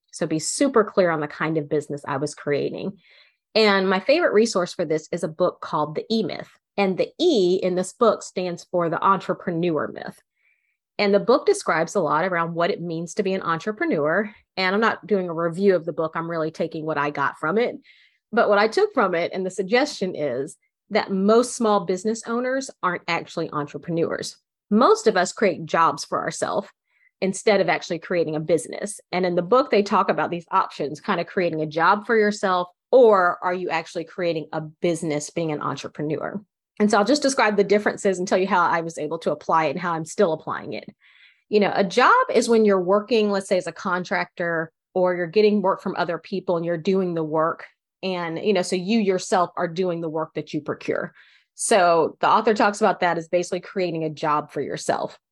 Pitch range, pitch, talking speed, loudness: 165-205 Hz, 185 Hz, 215 wpm, -22 LUFS